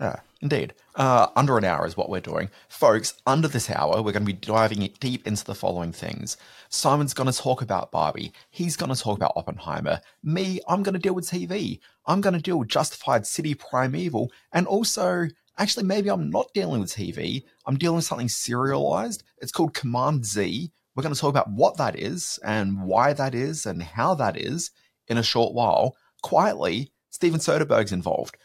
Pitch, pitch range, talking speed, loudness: 135 Hz, 110-170 Hz, 195 wpm, -25 LUFS